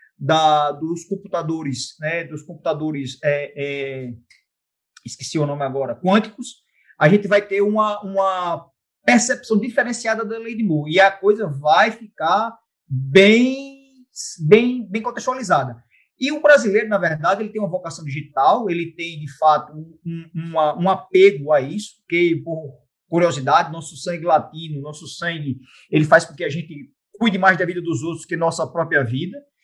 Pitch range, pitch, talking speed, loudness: 150-210 Hz, 170 Hz, 160 wpm, -19 LUFS